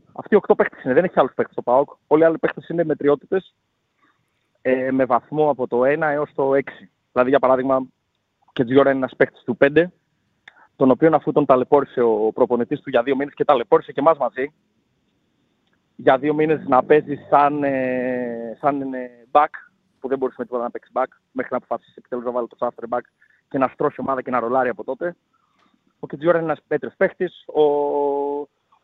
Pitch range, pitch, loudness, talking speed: 125-150 Hz, 140 Hz, -20 LUFS, 195 wpm